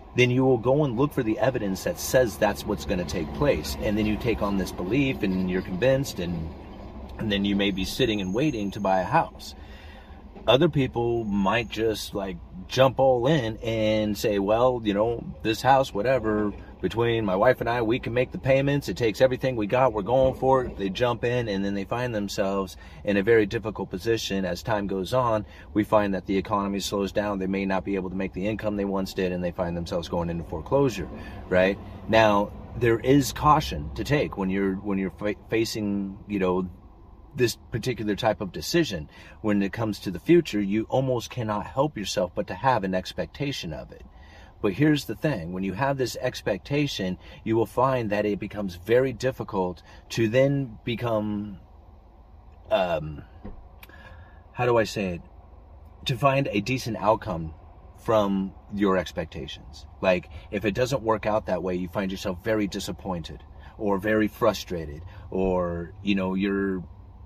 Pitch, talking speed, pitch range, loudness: 100 Hz, 185 wpm, 95-115 Hz, -26 LUFS